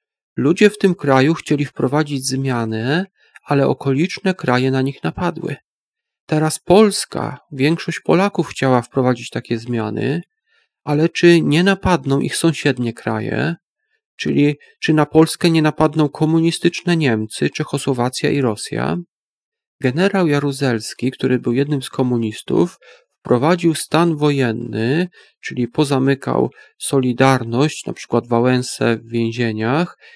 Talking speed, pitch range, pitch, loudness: 115 wpm, 125-170 Hz, 145 Hz, -18 LUFS